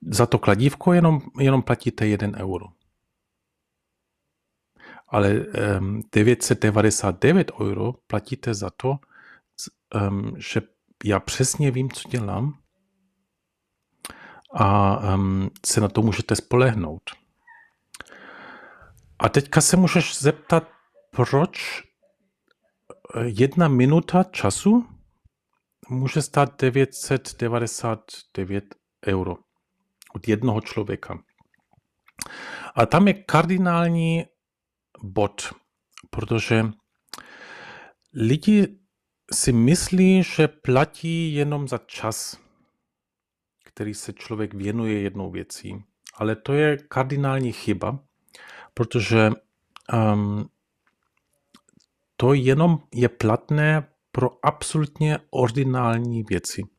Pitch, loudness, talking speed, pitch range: 125 Hz, -22 LUFS, 80 wpm, 105-150 Hz